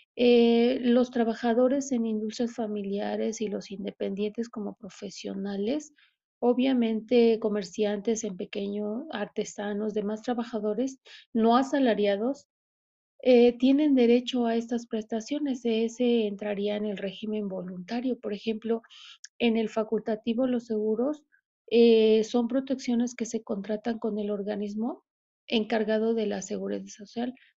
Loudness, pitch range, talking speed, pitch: -27 LUFS, 210-245 Hz, 115 wpm, 225 Hz